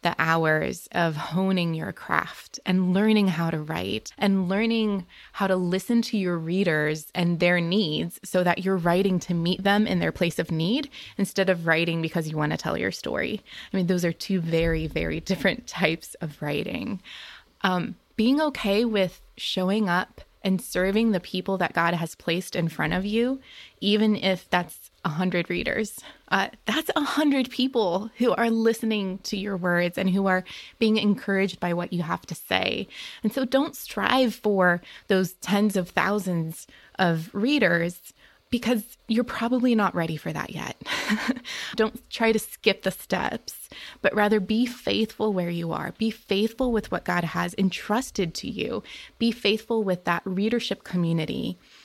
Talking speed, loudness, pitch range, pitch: 170 wpm, -25 LUFS, 175-220 Hz, 190 Hz